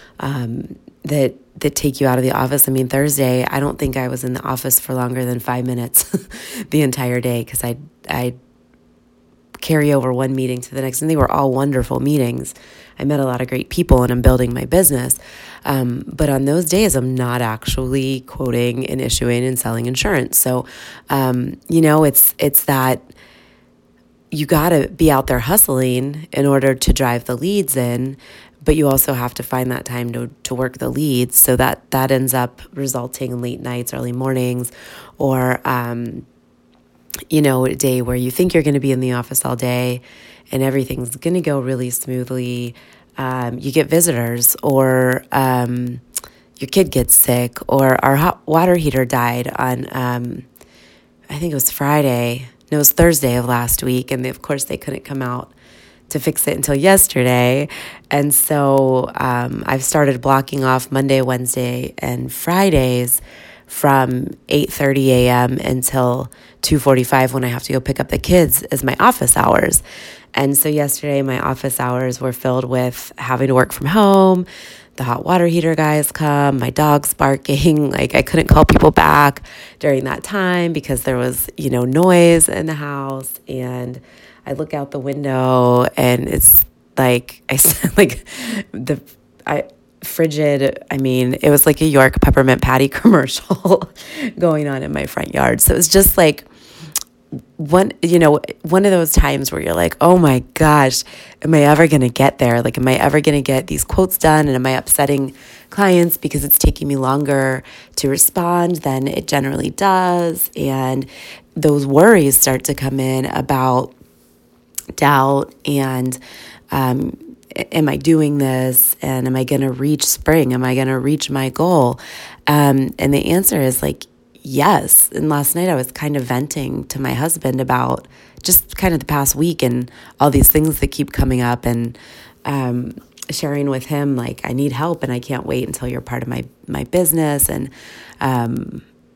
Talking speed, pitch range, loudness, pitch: 180 wpm, 125-150 Hz, -15 LUFS, 135 Hz